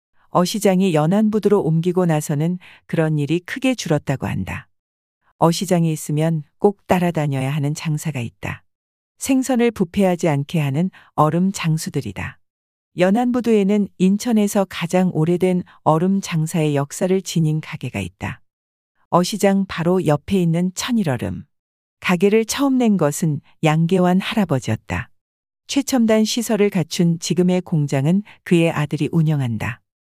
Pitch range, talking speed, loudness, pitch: 145-195 Hz, 295 characters per minute, -19 LUFS, 170 Hz